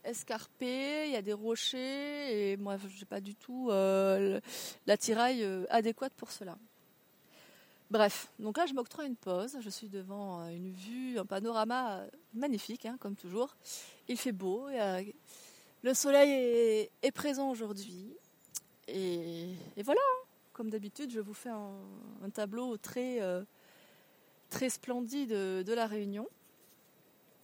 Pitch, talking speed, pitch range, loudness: 225 Hz, 150 wpm, 200-250 Hz, -35 LUFS